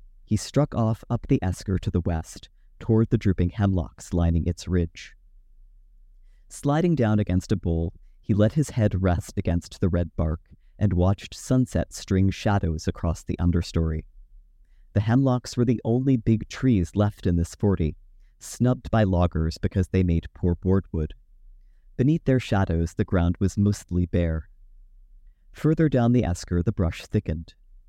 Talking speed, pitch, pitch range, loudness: 155 wpm, 95 Hz, 85-110 Hz, -25 LUFS